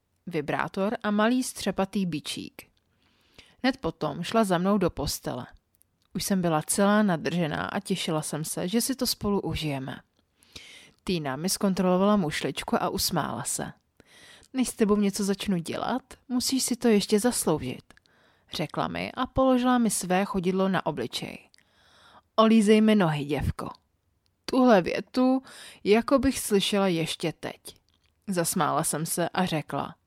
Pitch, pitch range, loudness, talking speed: 195 Hz, 160-220 Hz, -26 LUFS, 140 wpm